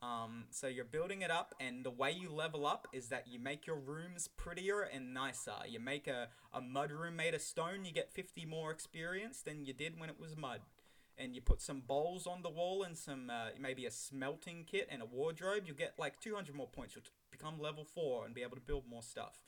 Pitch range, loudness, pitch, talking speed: 130-170 Hz, -44 LUFS, 155 Hz, 235 wpm